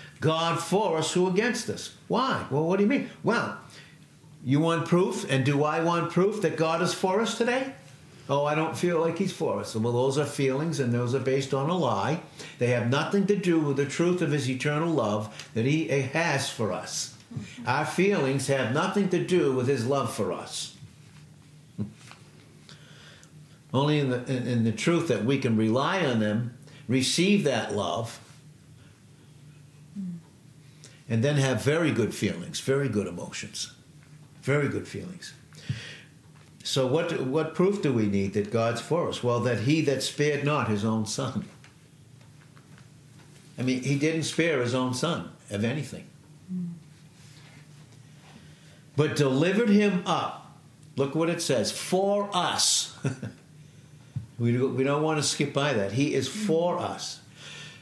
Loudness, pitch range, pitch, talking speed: -27 LUFS, 135-160 Hz, 145 Hz, 160 wpm